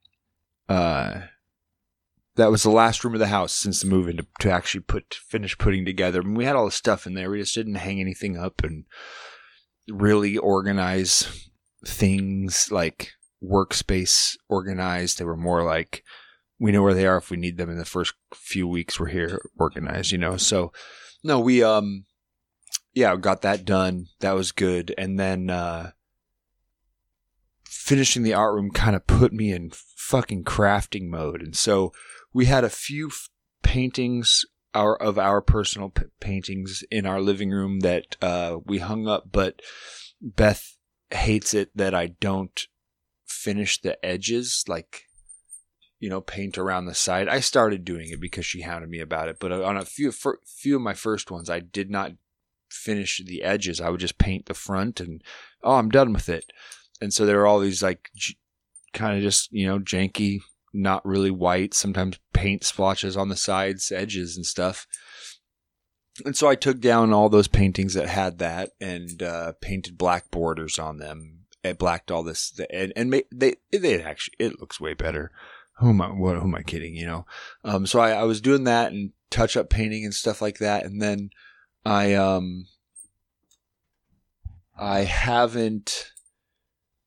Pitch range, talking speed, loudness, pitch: 90-105 Hz, 175 wpm, -24 LUFS, 95 Hz